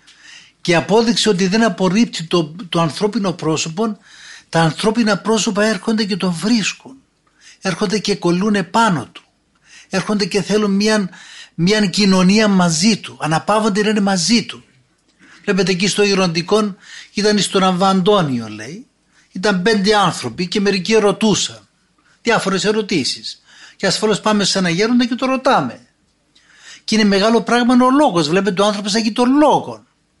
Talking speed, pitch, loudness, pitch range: 135 wpm, 205 Hz, -16 LUFS, 190-220 Hz